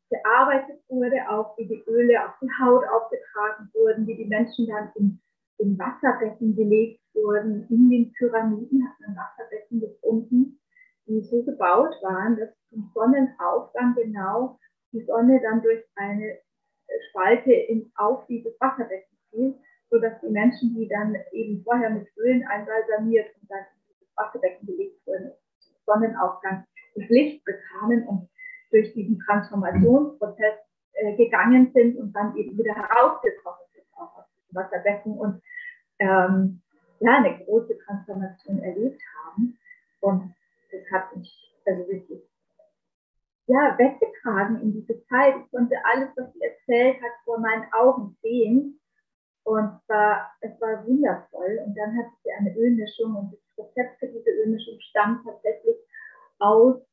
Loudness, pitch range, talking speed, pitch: -23 LUFS, 210-255 Hz, 140 wpm, 225 Hz